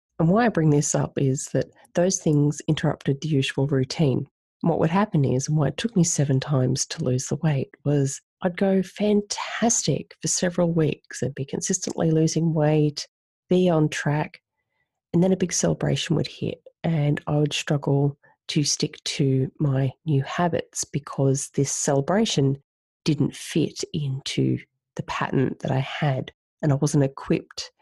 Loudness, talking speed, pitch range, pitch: -24 LUFS, 165 wpm, 140-175 Hz, 150 Hz